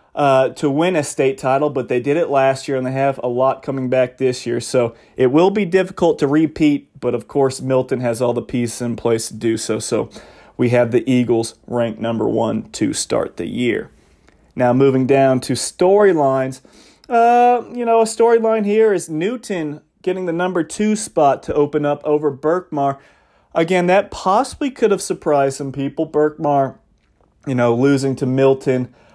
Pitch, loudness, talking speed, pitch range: 140 Hz, -17 LUFS, 185 wpm, 125-165 Hz